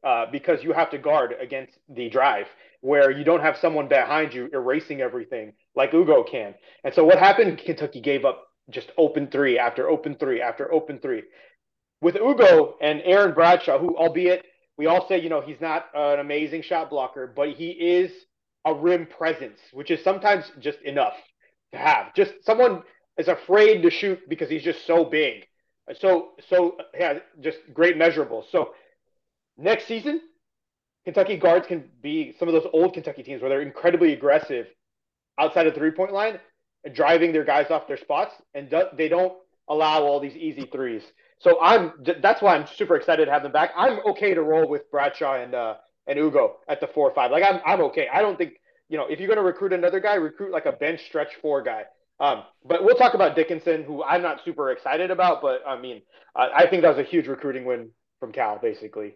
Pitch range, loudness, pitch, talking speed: 150-205 Hz, -22 LUFS, 170 Hz, 200 wpm